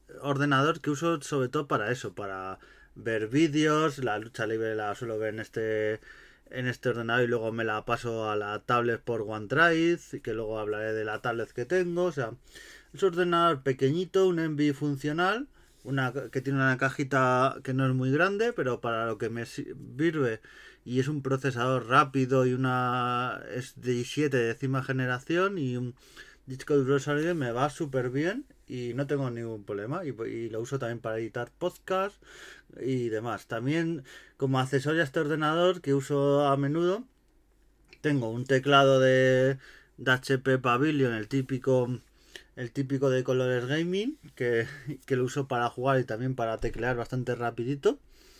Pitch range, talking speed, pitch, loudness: 120-150 Hz, 170 wpm, 130 Hz, -28 LUFS